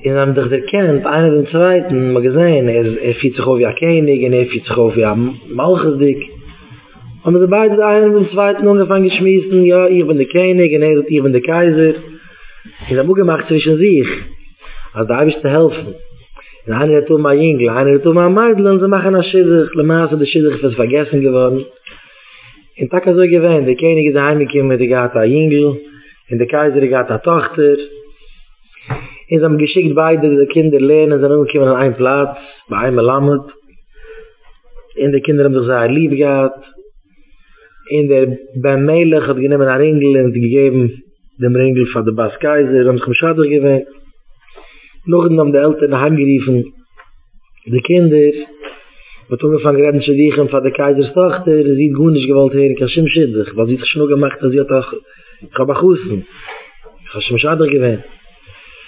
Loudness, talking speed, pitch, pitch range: -12 LUFS, 165 wpm, 145 Hz, 130-160 Hz